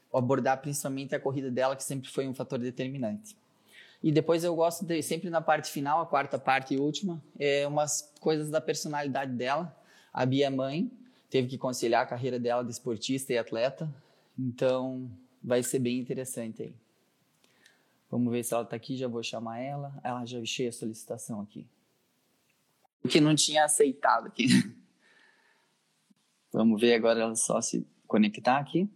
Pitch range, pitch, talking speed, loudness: 125-155 Hz, 135 Hz, 165 wpm, -29 LUFS